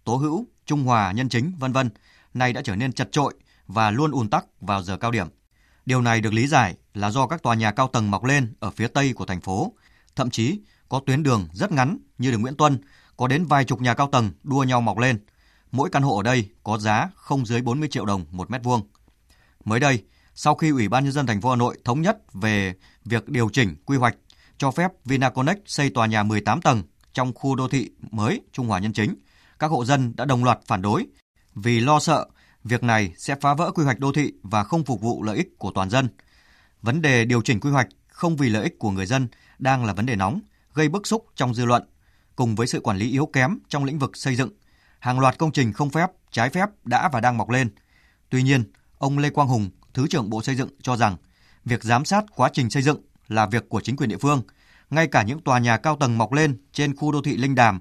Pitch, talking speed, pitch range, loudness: 125 Hz, 245 wpm, 110-140 Hz, -23 LUFS